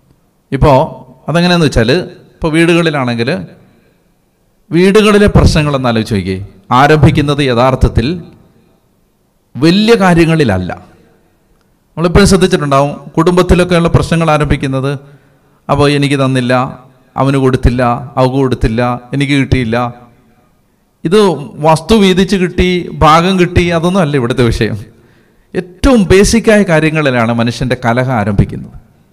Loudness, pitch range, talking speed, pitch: -10 LUFS, 125-175 Hz, 80 wpm, 145 Hz